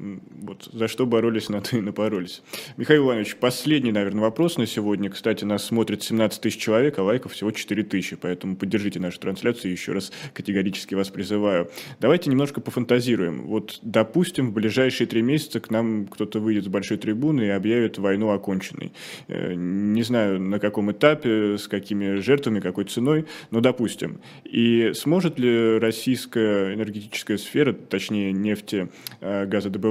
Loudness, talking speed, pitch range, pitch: -23 LUFS, 155 wpm, 100-120 Hz, 110 Hz